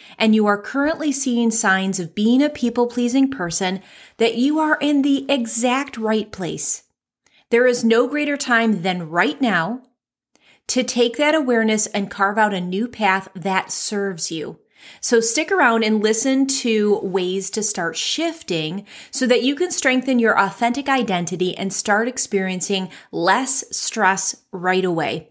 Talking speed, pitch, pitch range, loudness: 155 wpm, 225 Hz, 195-255 Hz, -19 LUFS